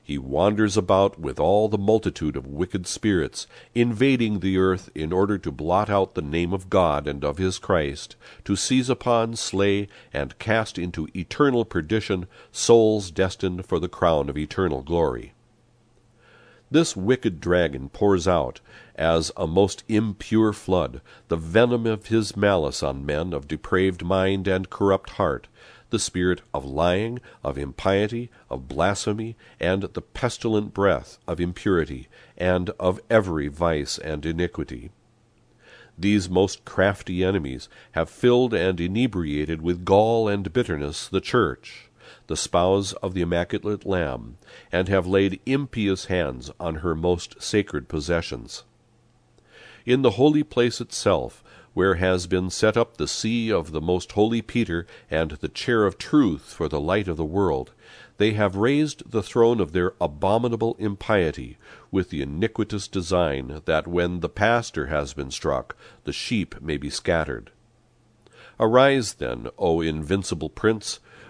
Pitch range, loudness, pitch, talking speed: 85-110 Hz, -24 LUFS, 95 Hz, 145 wpm